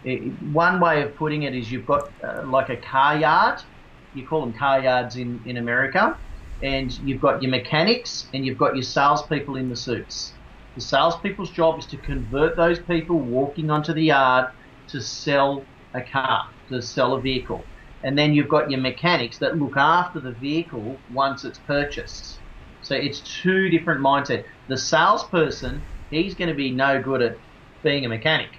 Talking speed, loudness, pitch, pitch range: 180 wpm, -22 LUFS, 135 Hz, 130-155 Hz